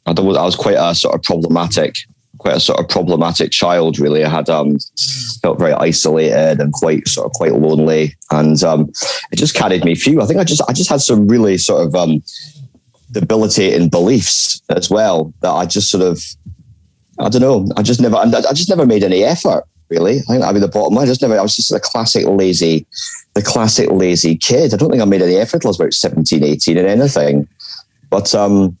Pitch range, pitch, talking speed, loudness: 75-95 Hz, 85 Hz, 215 wpm, -13 LUFS